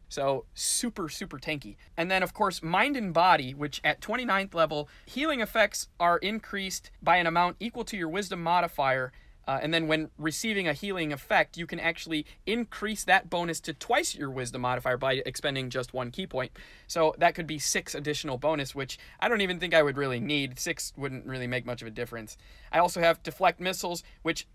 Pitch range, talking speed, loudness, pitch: 135-185 Hz, 200 wpm, -29 LUFS, 165 Hz